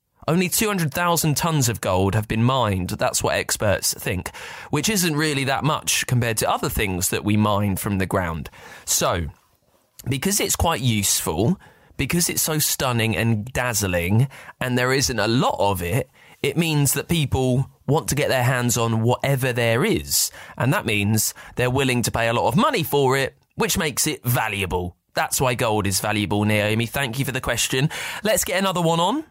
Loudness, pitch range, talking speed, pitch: -21 LUFS, 105-145 Hz, 185 wpm, 125 Hz